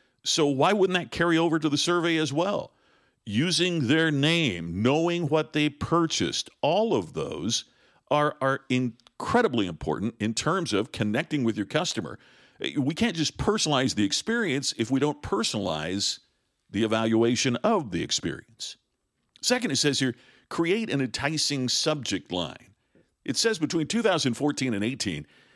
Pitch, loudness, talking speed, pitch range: 145 Hz, -26 LUFS, 145 wpm, 115-165 Hz